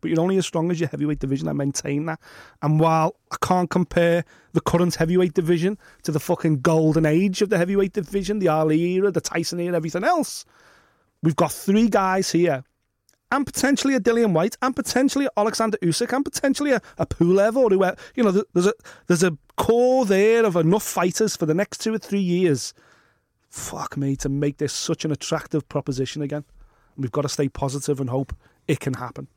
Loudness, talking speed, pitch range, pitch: -22 LUFS, 205 wpm, 155-205 Hz, 175 Hz